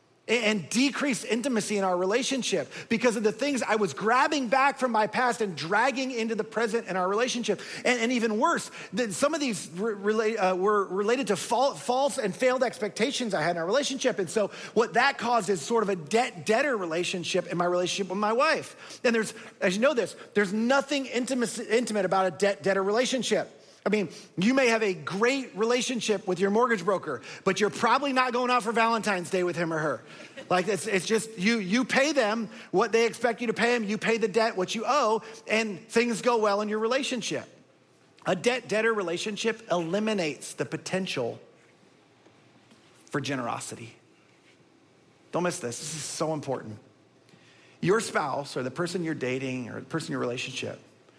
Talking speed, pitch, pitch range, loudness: 190 wpm, 215 Hz, 185-235 Hz, -27 LUFS